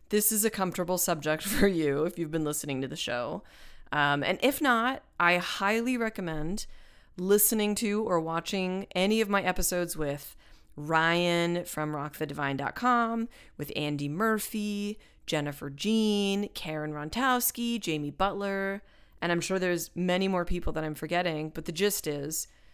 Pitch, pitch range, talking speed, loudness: 180 Hz, 155-205 Hz, 150 wpm, -29 LUFS